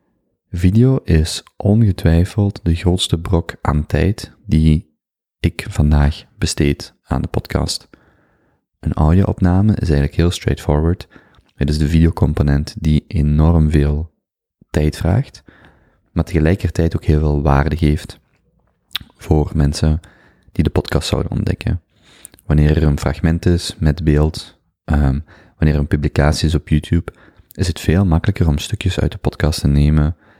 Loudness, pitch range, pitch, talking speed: -17 LUFS, 75-95 Hz, 80 Hz, 135 wpm